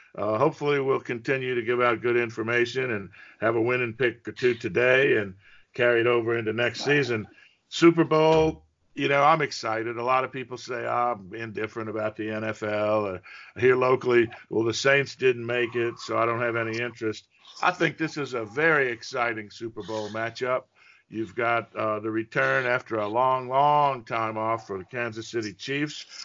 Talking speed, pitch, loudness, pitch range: 185 wpm, 120 Hz, -25 LUFS, 110-130 Hz